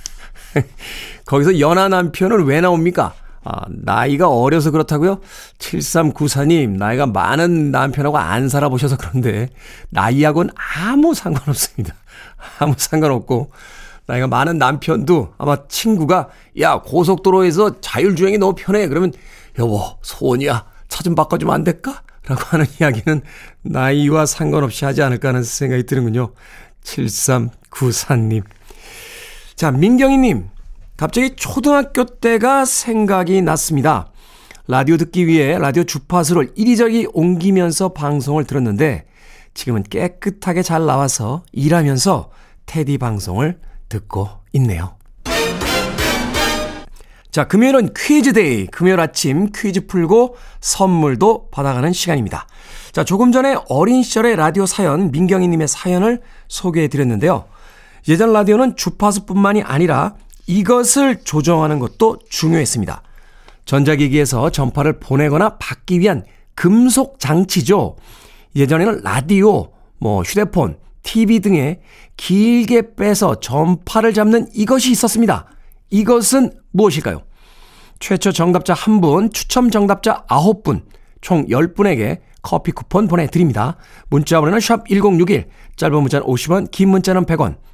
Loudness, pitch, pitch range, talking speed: -15 LUFS, 165 Hz, 140-200 Hz, 280 characters per minute